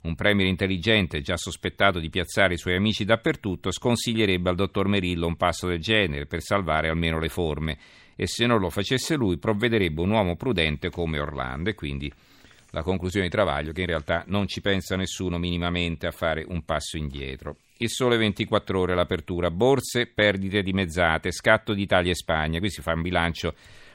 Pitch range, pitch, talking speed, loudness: 85-105 Hz, 90 Hz, 185 wpm, -25 LUFS